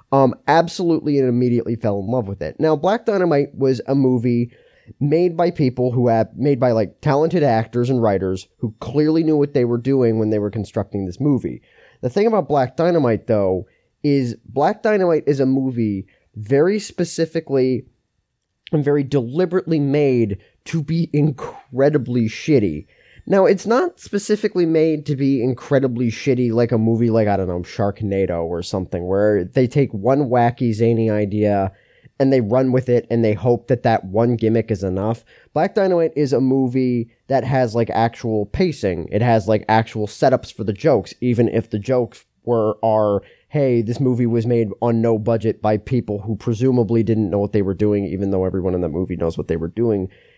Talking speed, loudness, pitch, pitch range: 185 wpm, -19 LUFS, 120 Hz, 110-140 Hz